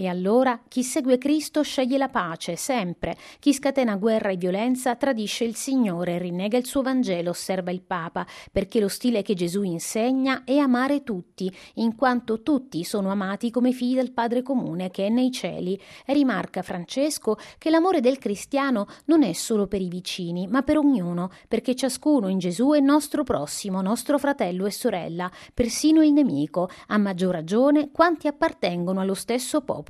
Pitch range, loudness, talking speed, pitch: 190-270 Hz, -24 LUFS, 175 wpm, 235 Hz